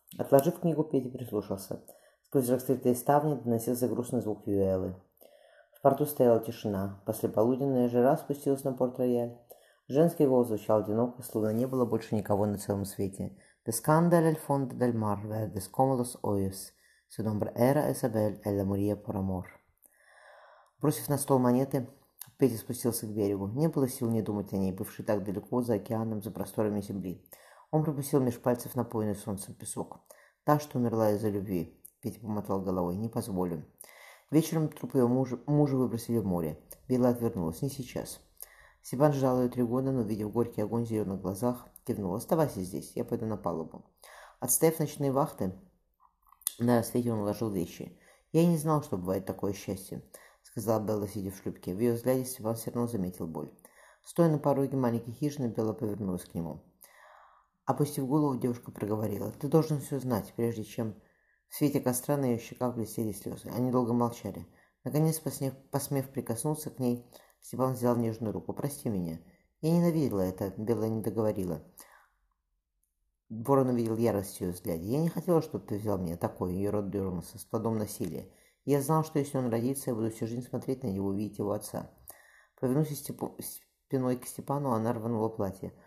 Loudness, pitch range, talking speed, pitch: -31 LUFS, 100-135 Hz, 160 wpm, 115 Hz